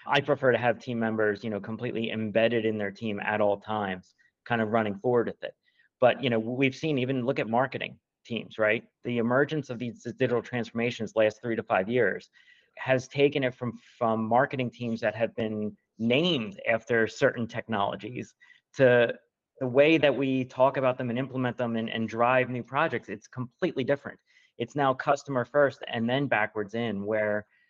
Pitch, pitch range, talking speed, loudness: 120 Hz, 110-130 Hz, 185 wpm, -28 LUFS